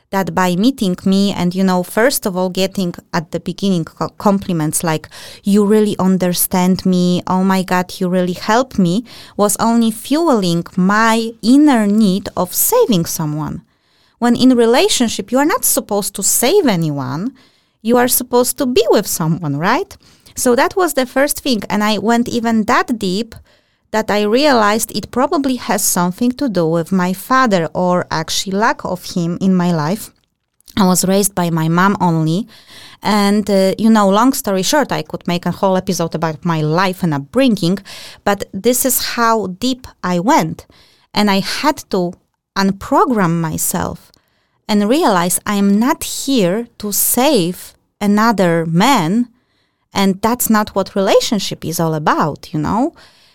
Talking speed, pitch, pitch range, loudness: 160 wpm, 200 Hz, 180-235 Hz, -15 LUFS